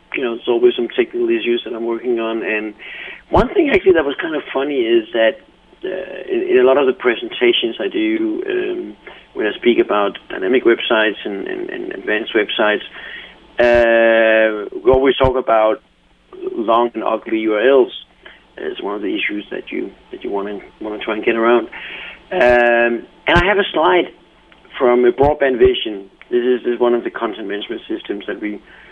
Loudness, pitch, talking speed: -16 LUFS, 175 Hz, 190 wpm